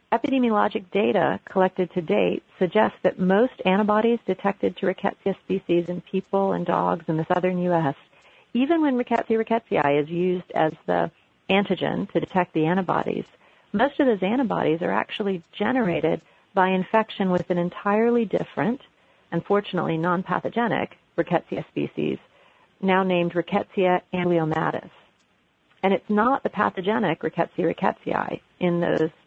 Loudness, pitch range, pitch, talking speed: -24 LUFS, 175-215 Hz, 185 Hz, 130 wpm